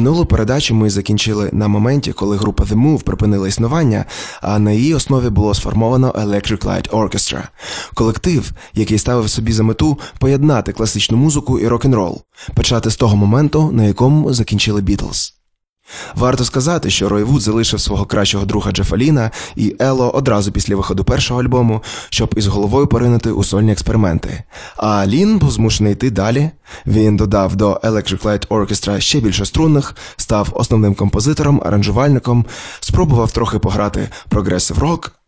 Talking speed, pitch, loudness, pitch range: 150 wpm, 110 Hz, -15 LUFS, 100-125 Hz